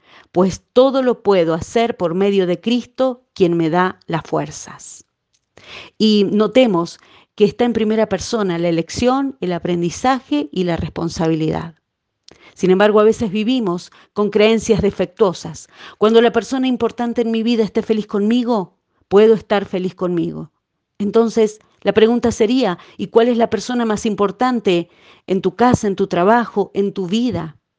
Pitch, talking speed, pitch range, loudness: 215 Hz, 150 wpm, 185-235 Hz, -17 LUFS